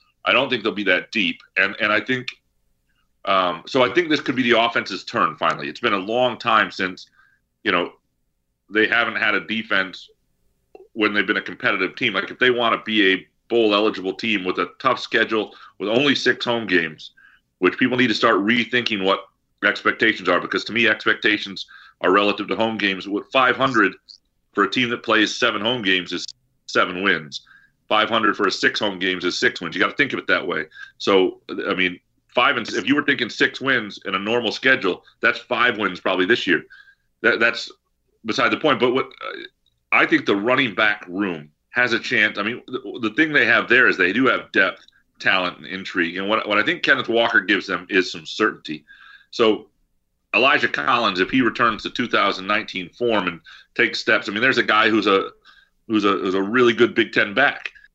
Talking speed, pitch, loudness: 210 wpm, 115 Hz, -19 LUFS